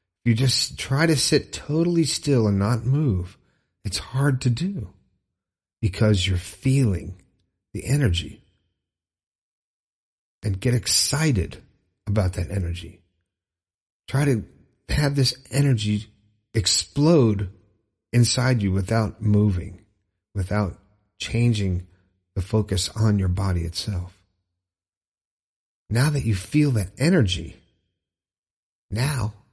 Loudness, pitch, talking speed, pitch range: -23 LUFS, 100 Hz, 100 wpm, 90-120 Hz